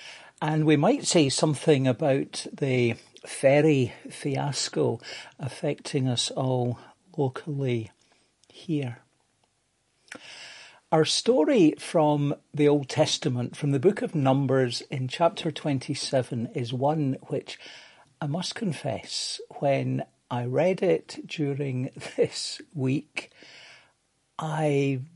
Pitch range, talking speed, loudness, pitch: 130-155 Hz, 100 wpm, -26 LUFS, 145 Hz